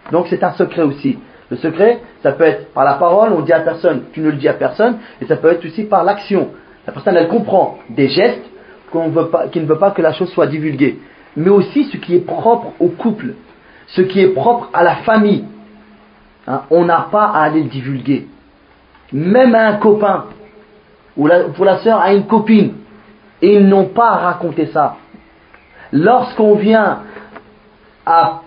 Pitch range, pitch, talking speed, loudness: 165-215 Hz, 195 Hz, 195 wpm, -13 LUFS